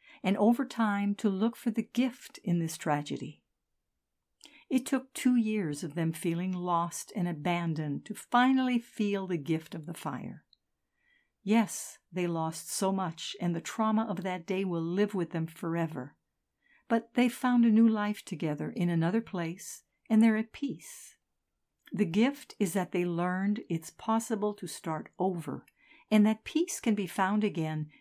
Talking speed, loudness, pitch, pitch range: 165 wpm, -31 LUFS, 200 Hz, 170-225 Hz